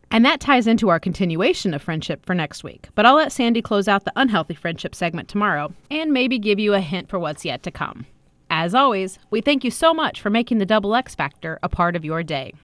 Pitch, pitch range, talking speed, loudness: 195 Hz, 170-235 Hz, 240 wpm, -20 LUFS